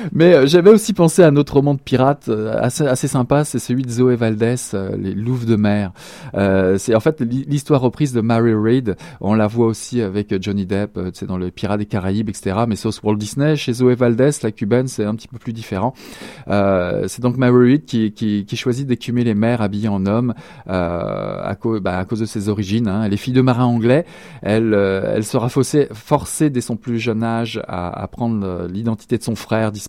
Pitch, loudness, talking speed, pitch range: 115 Hz, -17 LUFS, 220 wpm, 105-125 Hz